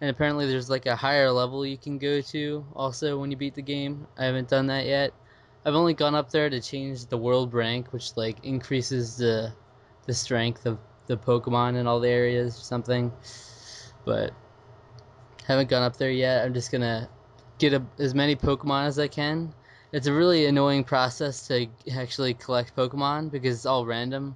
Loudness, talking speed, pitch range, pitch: -26 LUFS, 190 wpm, 120-140 Hz, 130 Hz